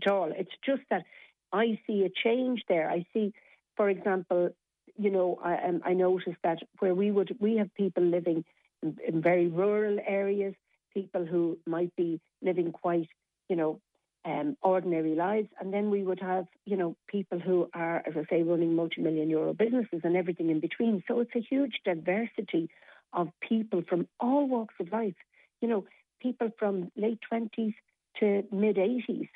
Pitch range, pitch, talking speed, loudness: 175-215 Hz, 190 Hz, 175 wpm, -30 LUFS